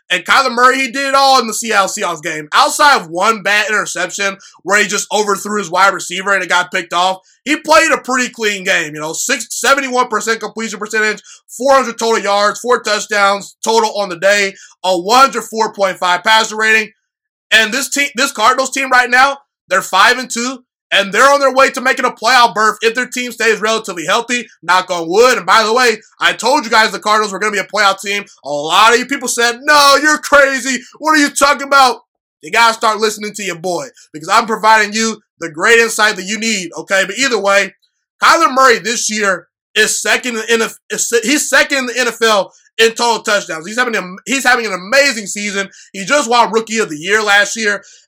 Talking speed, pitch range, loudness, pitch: 215 wpm, 200-250 Hz, -12 LUFS, 220 Hz